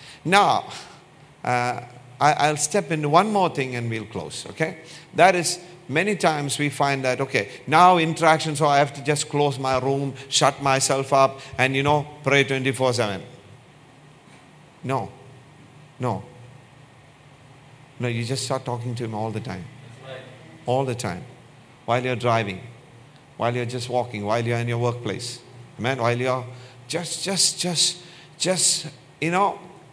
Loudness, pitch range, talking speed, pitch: -22 LUFS, 125-155 Hz, 150 wpm, 135 Hz